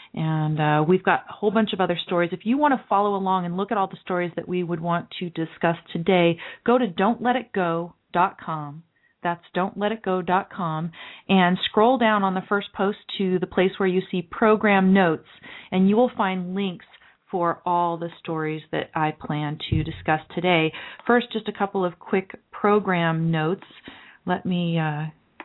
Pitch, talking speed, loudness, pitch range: 185 Hz, 175 wpm, -23 LUFS, 170-200 Hz